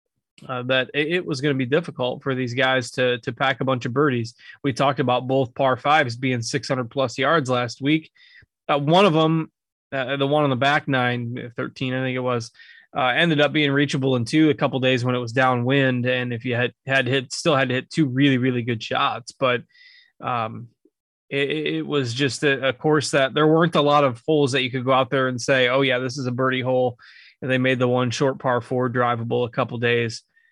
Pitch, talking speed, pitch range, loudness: 130 Hz, 230 wpm, 125-145 Hz, -21 LUFS